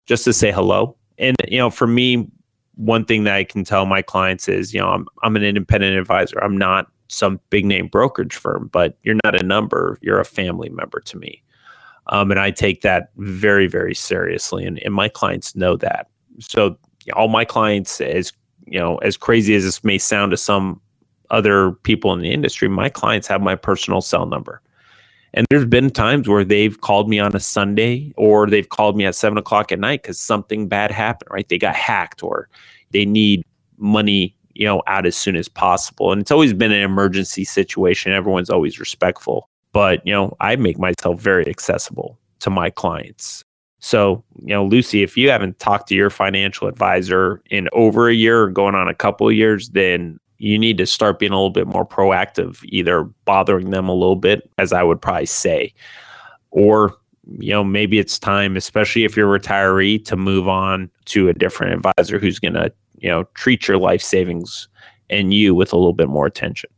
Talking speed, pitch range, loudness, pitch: 200 wpm, 95-110 Hz, -17 LUFS, 100 Hz